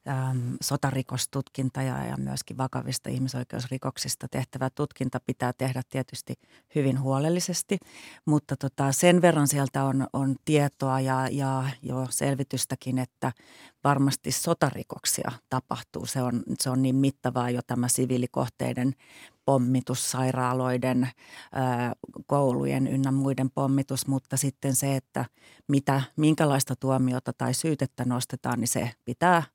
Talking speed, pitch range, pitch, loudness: 115 wpm, 125-140 Hz, 130 Hz, -27 LUFS